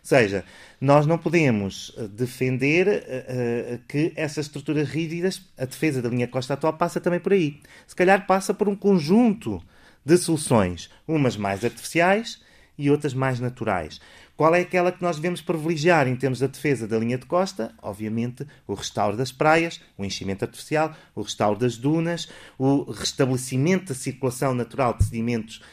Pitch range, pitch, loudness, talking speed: 120-170 Hz, 140 Hz, -23 LUFS, 165 wpm